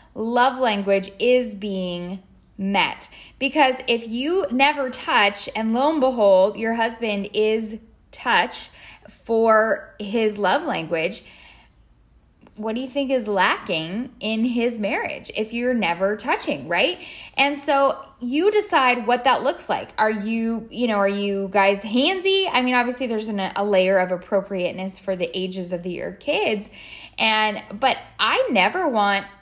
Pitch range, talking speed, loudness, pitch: 200-255 Hz, 145 wpm, -21 LUFS, 220 Hz